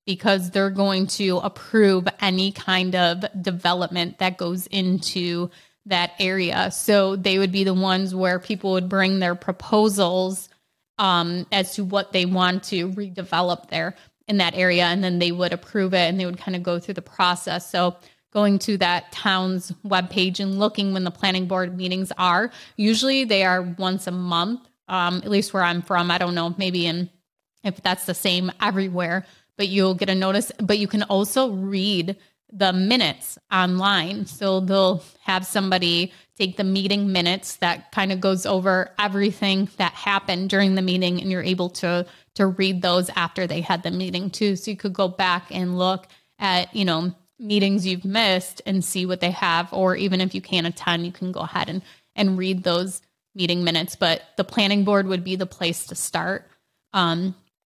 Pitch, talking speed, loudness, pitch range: 185 Hz, 185 wpm, -22 LUFS, 180-195 Hz